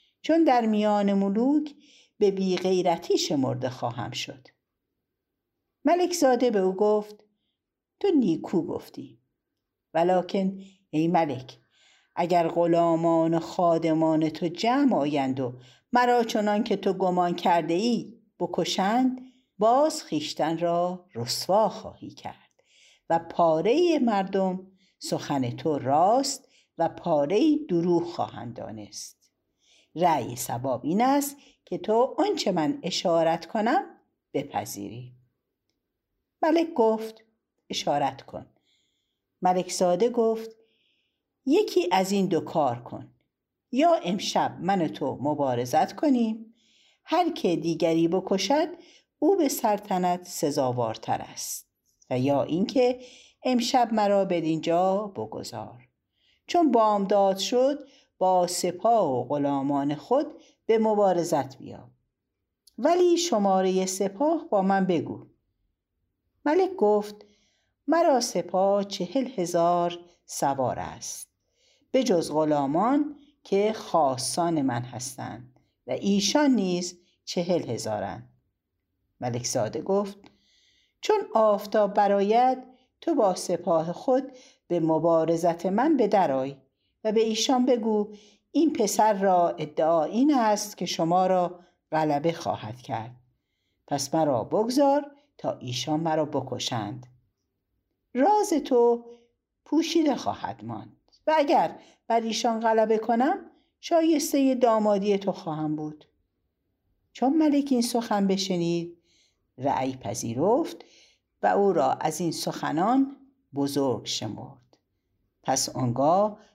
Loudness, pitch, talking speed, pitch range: -25 LUFS, 190 Hz, 105 wpm, 155-245 Hz